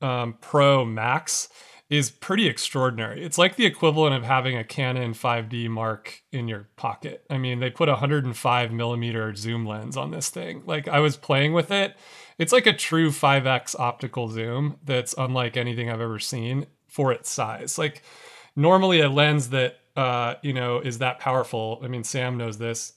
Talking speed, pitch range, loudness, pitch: 180 wpm, 120-145 Hz, -24 LUFS, 130 Hz